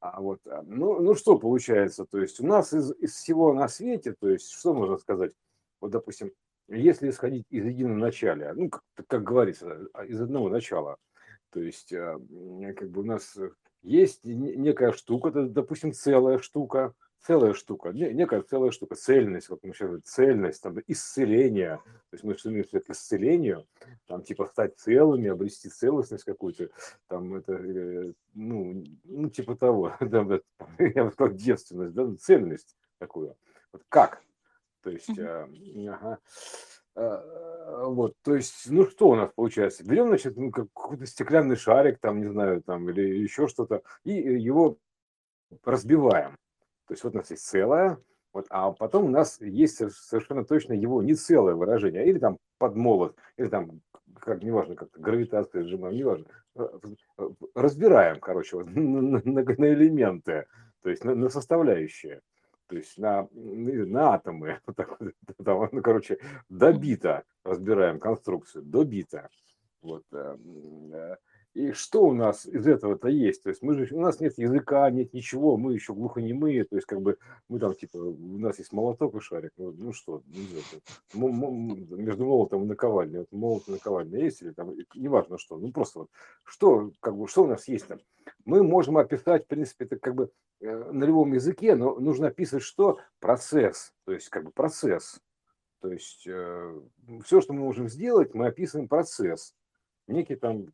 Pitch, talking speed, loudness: 135 Hz, 160 wpm, -26 LUFS